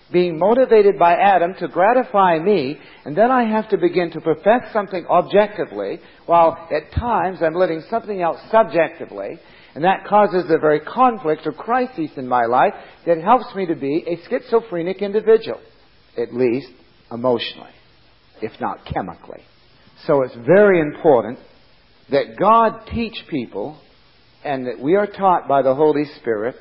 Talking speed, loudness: 150 wpm, -18 LUFS